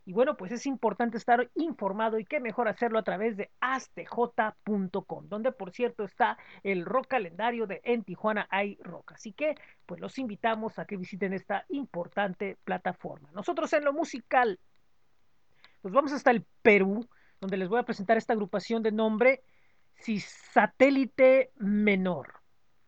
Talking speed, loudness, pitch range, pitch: 150 wpm, -29 LUFS, 200-255 Hz, 225 Hz